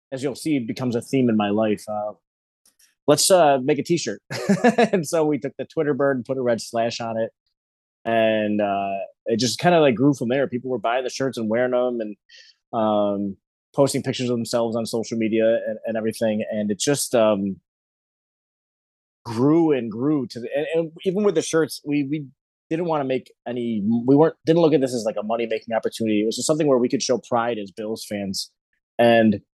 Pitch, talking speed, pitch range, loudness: 120 Hz, 215 wpm, 110-145 Hz, -22 LUFS